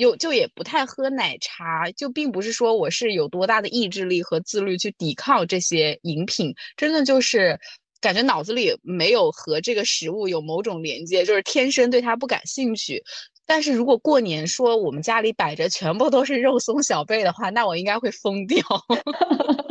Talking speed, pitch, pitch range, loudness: 285 characters per minute, 240 Hz, 195-295 Hz, -21 LUFS